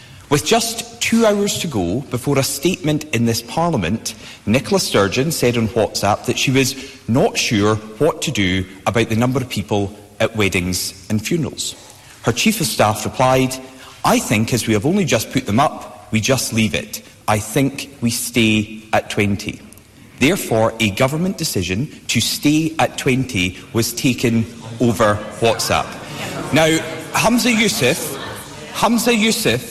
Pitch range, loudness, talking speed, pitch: 110-150 Hz, -18 LUFS, 155 wpm, 120 Hz